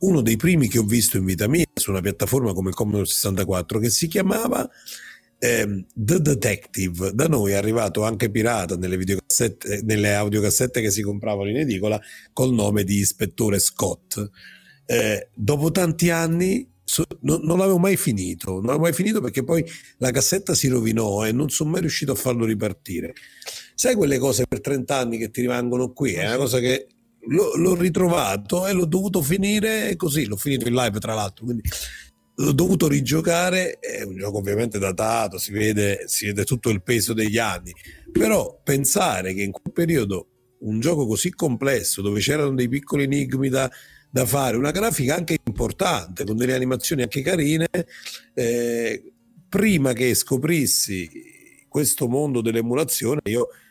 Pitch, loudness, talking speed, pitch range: 125 Hz, -22 LUFS, 170 wpm, 105-160 Hz